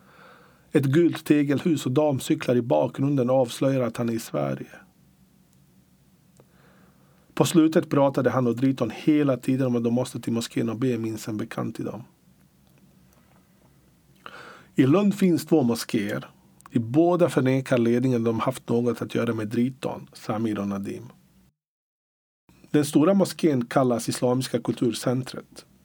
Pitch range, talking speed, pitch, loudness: 120-150 Hz, 140 wpm, 130 Hz, -24 LUFS